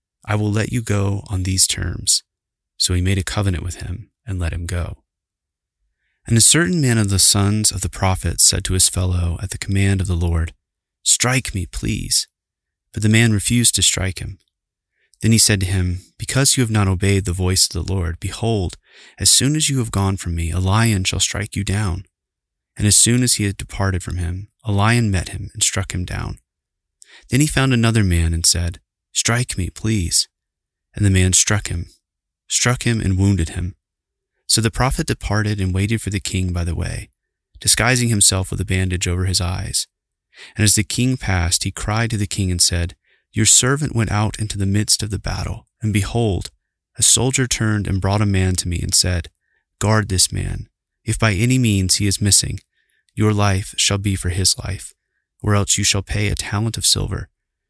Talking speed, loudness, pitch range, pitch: 205 wpm, -17 LUFS, 90-110 Hz, 100 Hz